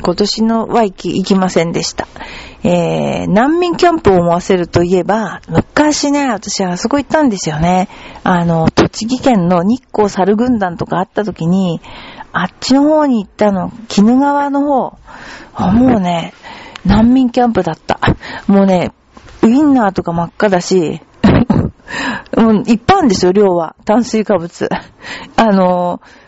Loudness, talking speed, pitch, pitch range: -13 LUFS, 290 characters per minute, 205 Hz, 180-245 Hz